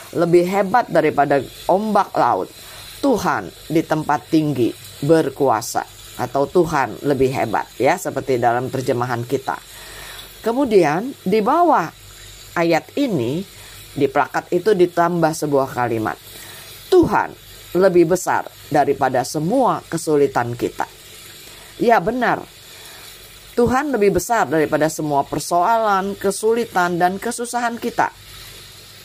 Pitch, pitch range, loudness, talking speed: 155 Hz, 130-195 Hz, -19 LUFS, 100 wpm